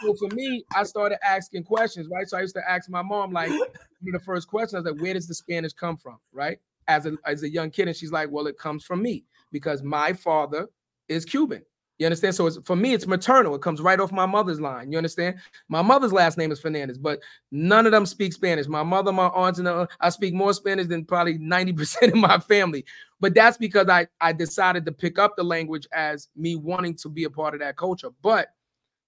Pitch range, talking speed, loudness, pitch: 160-195 Hz, 235 wpm, -23 LUFS, 180 Hz